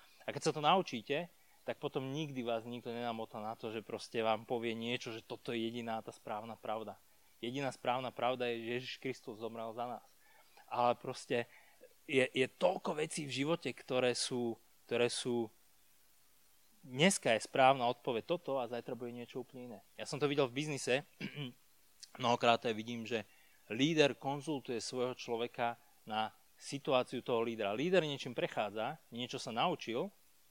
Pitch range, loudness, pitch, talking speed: 115-135 Hz, -37 LUFS, 125 Hz, 160 wpm